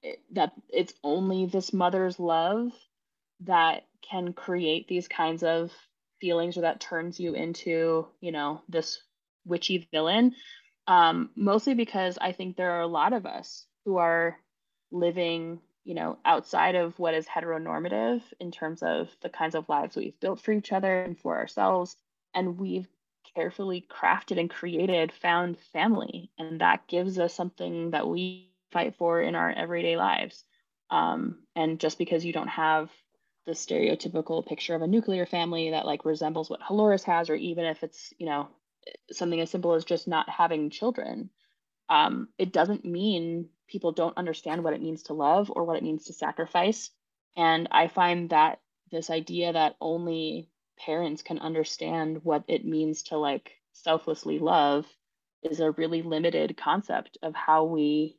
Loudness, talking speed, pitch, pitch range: -28 LUFS, 165 wpm, 170 Hz, 160-180 Hz